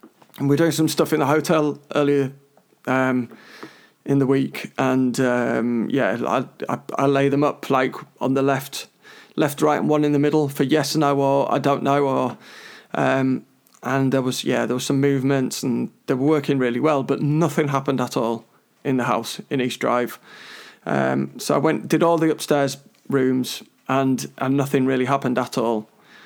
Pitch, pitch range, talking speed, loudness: 140 Hz, 130-145 Hz, 195 wpm, -21 LUFS